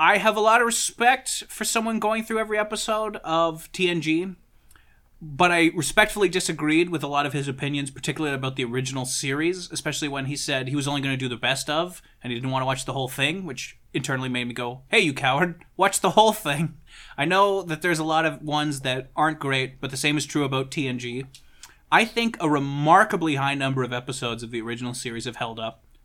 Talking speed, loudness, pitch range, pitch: 220 wpm, -24 LUFS, 130-175 Hz, 150 Hz